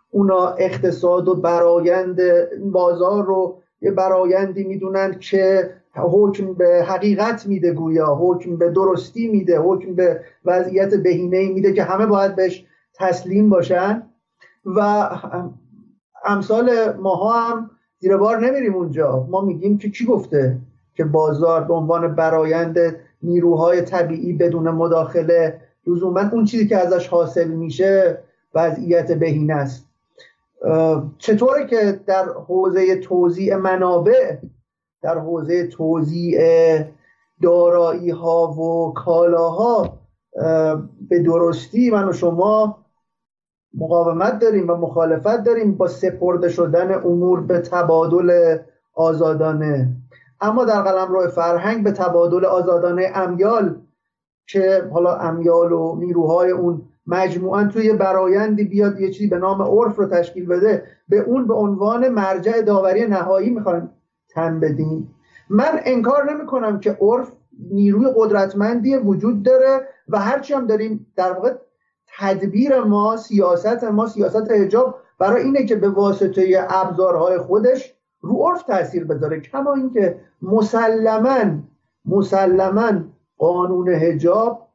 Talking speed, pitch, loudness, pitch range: 120 wpm, 185 Hz, -17 LUFS, 170-210 Hz